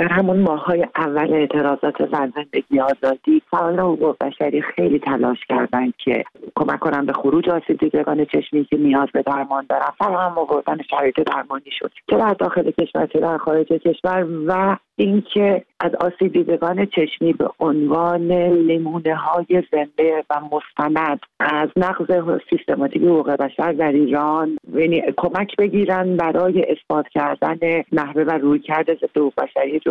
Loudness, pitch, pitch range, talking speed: -19 LUFS, 160 Hz, 150-180 Hz, 145 wpm